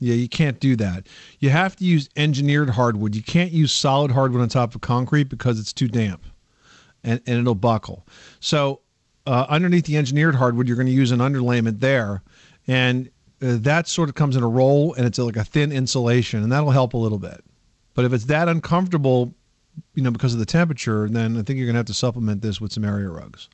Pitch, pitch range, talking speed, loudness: 125 Hz, 115-145 Hz, 225 wpm, -20 LUFS